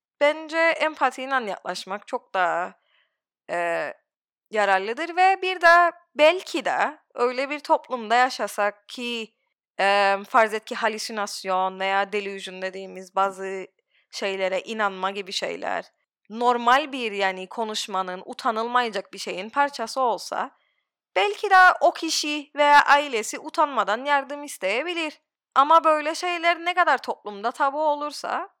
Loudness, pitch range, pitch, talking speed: -23 LUFS, 195-300 Hz, 245 Hz, 115 wpm